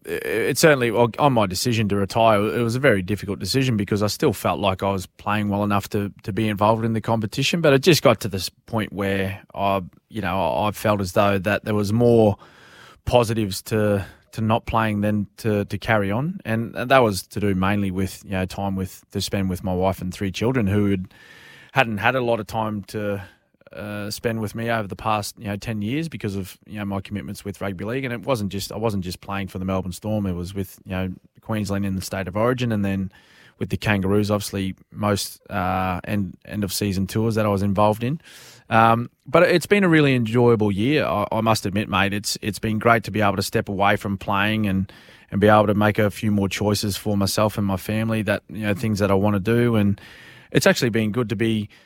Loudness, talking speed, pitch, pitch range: -22 LUFS, 235 wpm, 105 Hz, 100-115 Hz